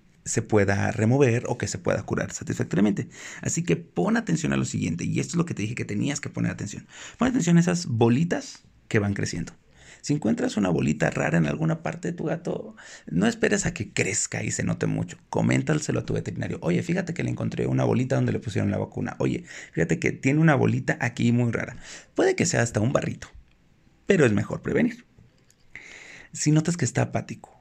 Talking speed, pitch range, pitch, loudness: 210 wpm, 100-140 Hz, 120 Hz, -25 LUFS